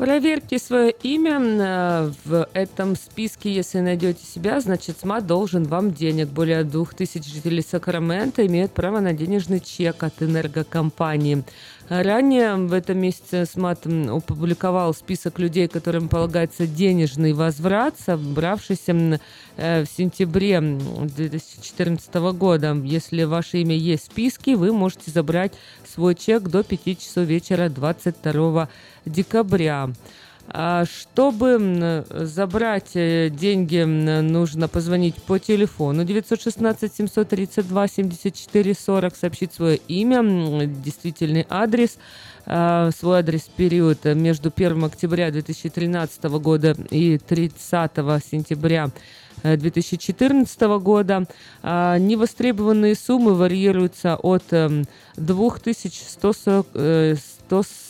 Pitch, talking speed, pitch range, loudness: 175 Hz, 95 wpm, 160-195 Hz, -21 LUFS